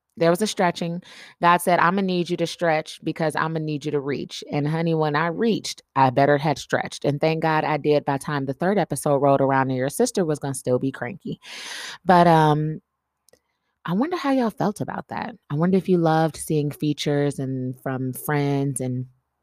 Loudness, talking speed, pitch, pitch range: -22 LUFS, 215 wpm, 155 Hz, 140-175 Hz